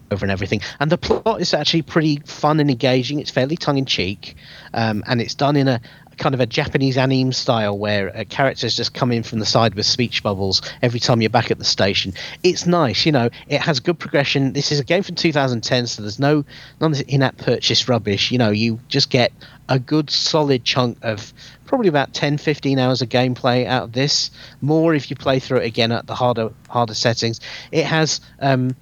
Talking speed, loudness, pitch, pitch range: 215 wpm, -19 LUFS, 130 Hz, 115-145 Hz